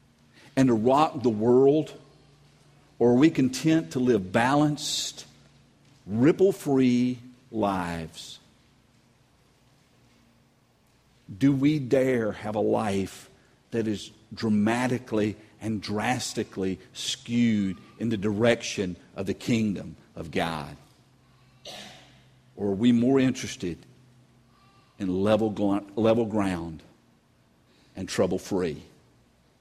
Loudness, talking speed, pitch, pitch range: -26 LUFS, 95 wpm, 120 Hz, 105-130 Hz